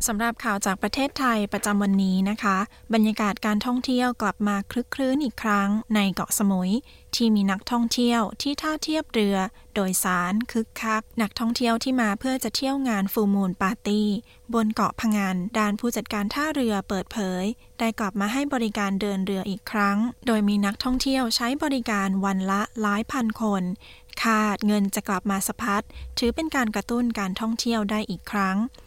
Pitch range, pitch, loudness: 200-235 Hz, 215 Hz, -25 LUFS